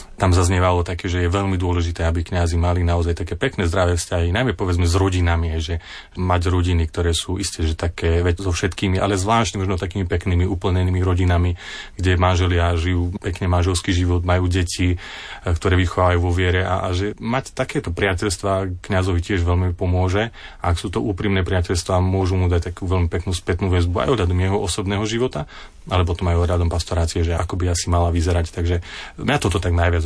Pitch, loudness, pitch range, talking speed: 90 Hz, -20 LUFS, 85-95 Hz, 180 wpm